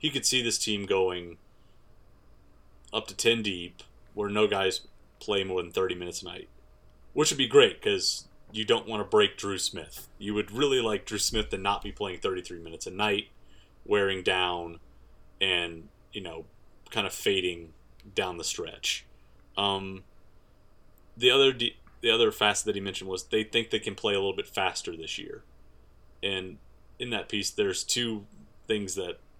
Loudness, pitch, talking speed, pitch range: -28 LUFS, 100 Hz, 180 wpm, 90-115 Hz